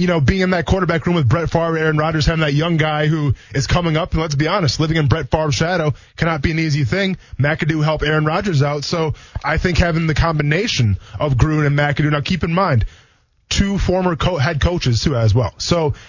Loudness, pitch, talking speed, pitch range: -17 LUFS, 155 Hz, 230 wpm, 135-165 Hz